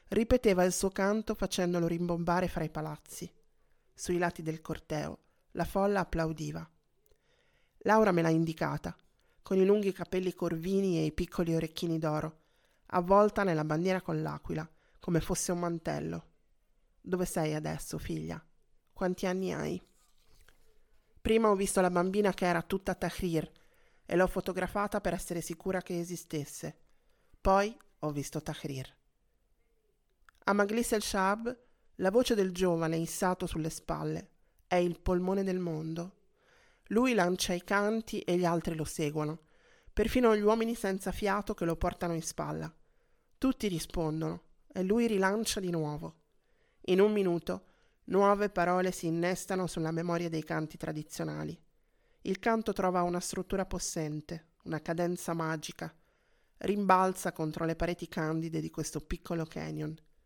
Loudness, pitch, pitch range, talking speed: -32 LUFS, 175 Hz, 160-195 Hz, 140 wpm